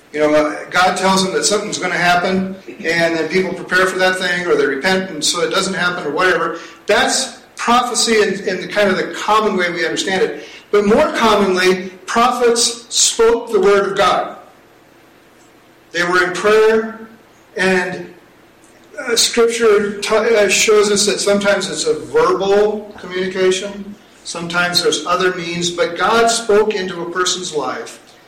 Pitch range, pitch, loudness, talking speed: 180-215 Hz, 195 Hz, -15 LUFS, 160 wpm